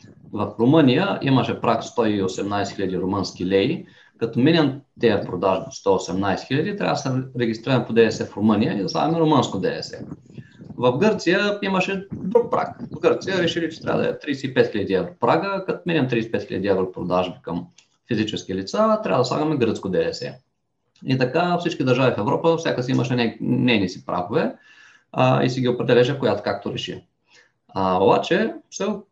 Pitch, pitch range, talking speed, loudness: 125 Hz, 115-165 Hz, 160 wpm, -21 LUFS